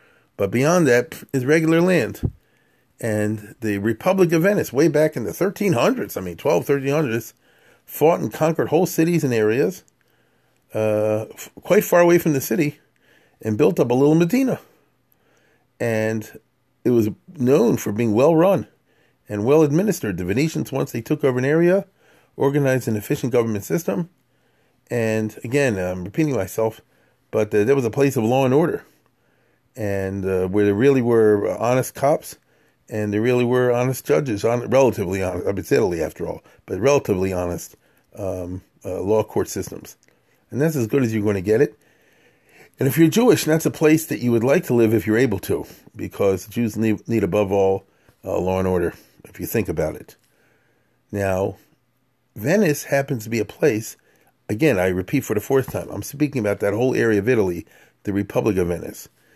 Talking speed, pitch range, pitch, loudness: 180 wpm, 105-145 Hz, 120 Hz, -20 LUFS